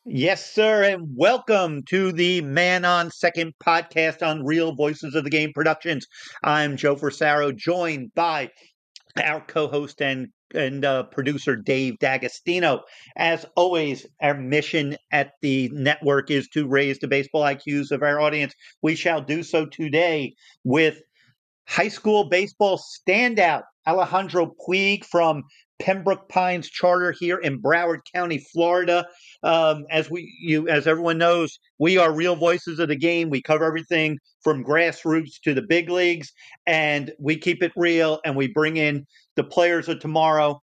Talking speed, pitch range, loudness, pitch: 150 wpm, 145-175 Hz, -22 LUFS, 160 Hz